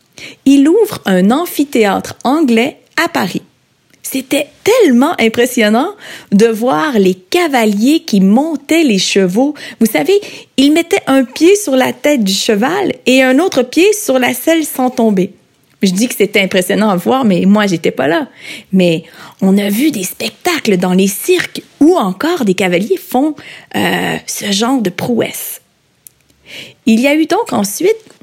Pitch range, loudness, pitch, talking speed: 200-300 Hz, -12 LUFS, 245 Hz, 160 wpm